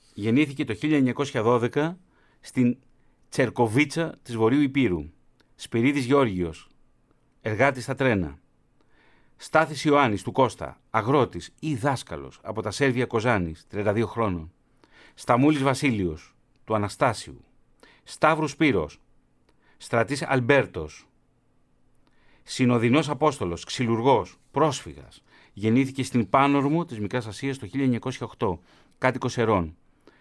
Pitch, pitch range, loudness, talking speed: 125 Hz, 110-140 Hz, -25 LUFS, 95 wpm